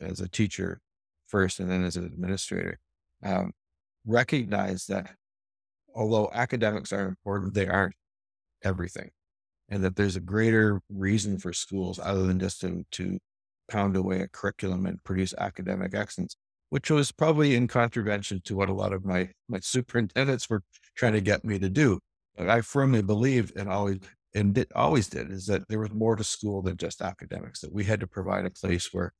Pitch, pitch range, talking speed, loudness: 100 Hz, 95-110 Hz, 180 wpm, -28 LUFS